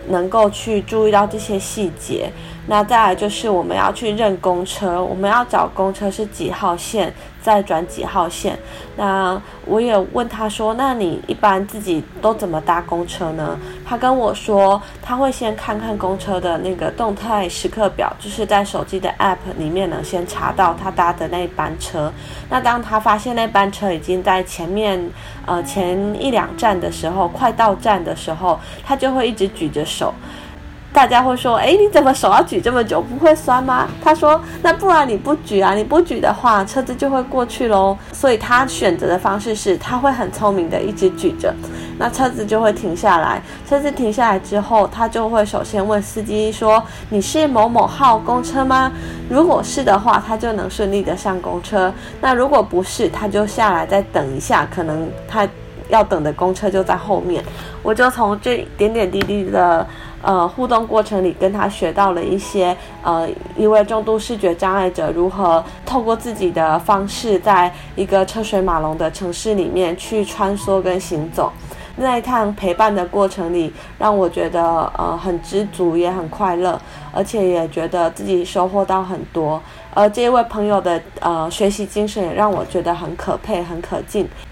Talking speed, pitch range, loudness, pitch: 265 characters per minute, 180-220 Hz, -17 LUFS, 200 Hz